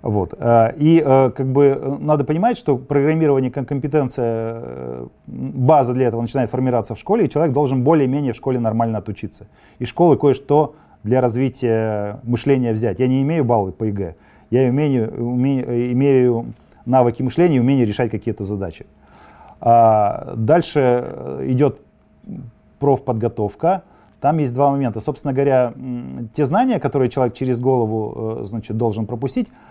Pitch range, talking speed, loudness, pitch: 115-140 Hz, 135 wpm, -18 LUFS, 125 Hz